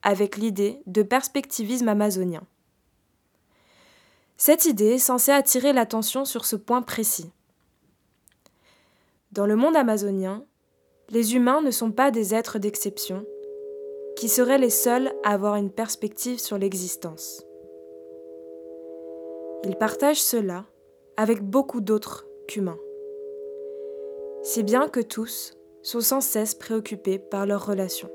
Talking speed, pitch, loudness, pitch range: 115 wpm, 220 Hz, -23 LUFS, 195-265 Hz